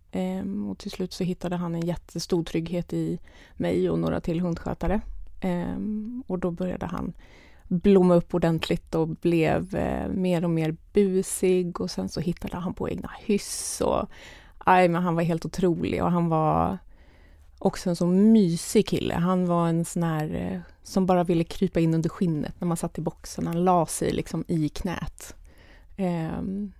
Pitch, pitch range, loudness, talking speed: 175 Hz, 160-185 Hz, -26 LUFS, 165 wpm